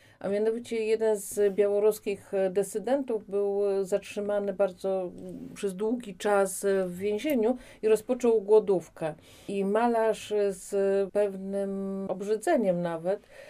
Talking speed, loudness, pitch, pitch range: 100 wpm, -28 LUFS, 205 Hz, 195-220 Hz